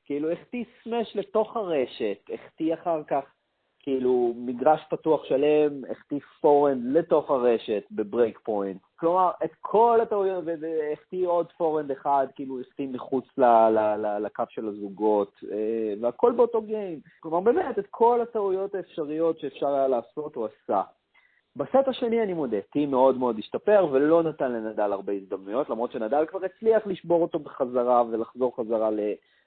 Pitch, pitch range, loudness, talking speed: 150 Hz, 120-185 Hz, -26 LUFS, 155 wpm